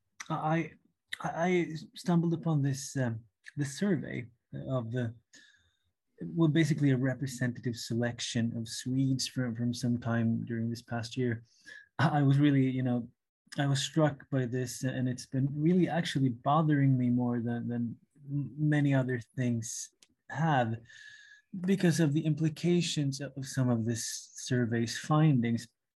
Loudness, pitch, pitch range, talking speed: -31 LUFS, 135 Hz, 120-155 Hz, 135 wpm